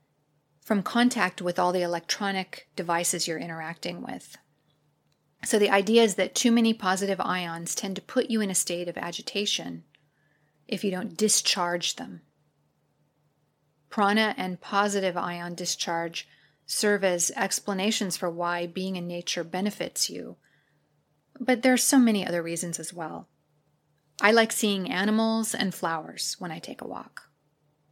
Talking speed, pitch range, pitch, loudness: 145 wpm, 170-210 Hz, 185 Hz, -26 LUFS